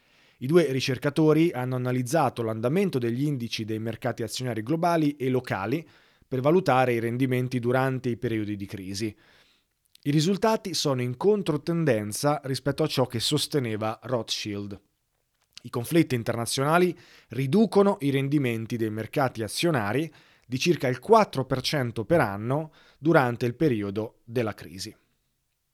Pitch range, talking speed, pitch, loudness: 115-155 Hz, 125 wpm, 130 Hz, -26 LUFS